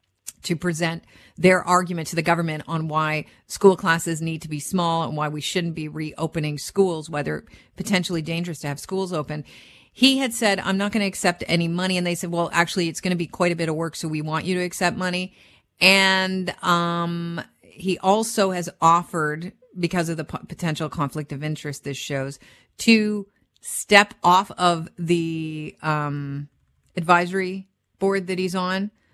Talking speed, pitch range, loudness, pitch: 180 wpm, 155-185 Hz, -22 LUFS, 170 Hz